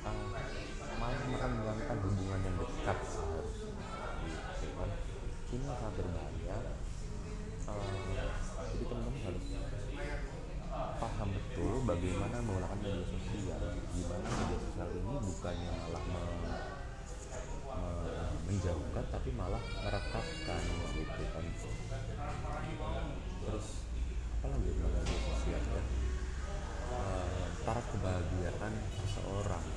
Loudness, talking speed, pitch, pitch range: -40 LUFS, 85 wpm, 95 Hz, 85-105 Hz